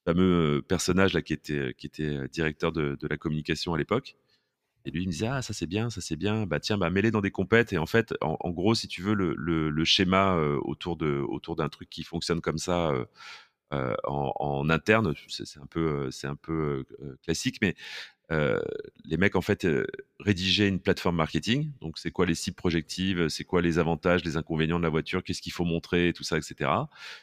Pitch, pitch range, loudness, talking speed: 85 Hz, 80-95 Hz, -28 LUFS, 225 wpm